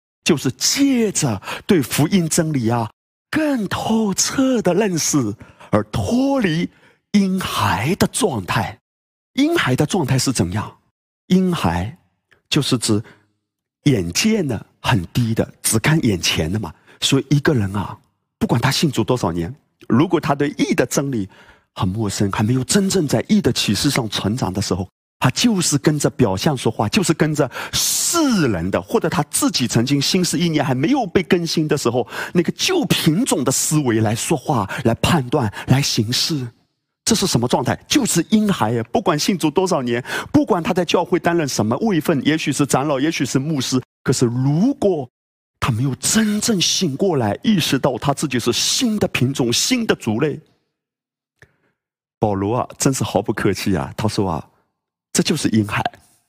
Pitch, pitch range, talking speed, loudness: 140 Hz, 115-180 Hz, 245 characters per minute, -18 LUFS